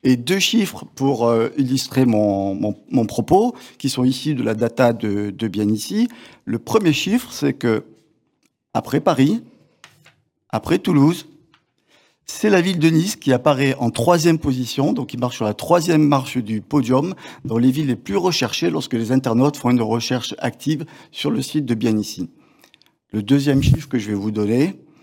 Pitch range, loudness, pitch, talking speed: 115-155 Hz, -19 LUFS, 130 Hz, 175 wpm